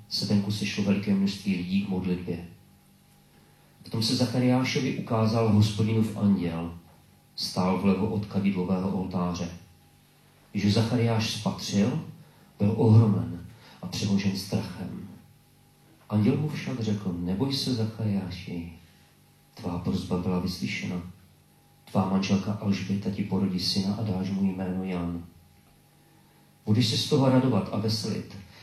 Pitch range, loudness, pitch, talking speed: 90-110 Hz, -27 LUFS, 100 Hz, 120 wpm